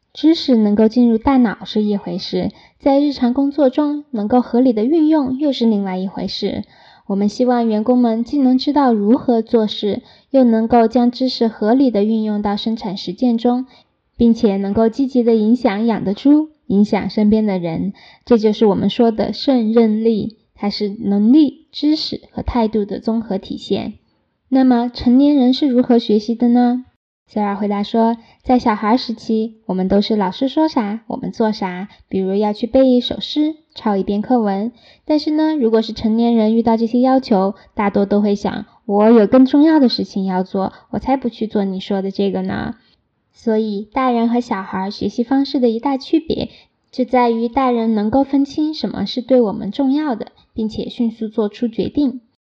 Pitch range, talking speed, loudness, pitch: 210-255 Hz, 270 characters per minute, -16 LUFS, 230 Hz